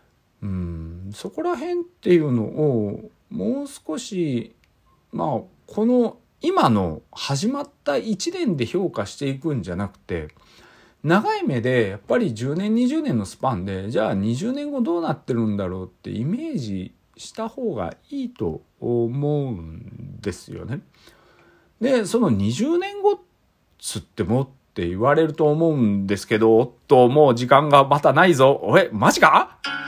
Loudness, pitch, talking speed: -21 LUFS, 135 Hz, 265 characters per minute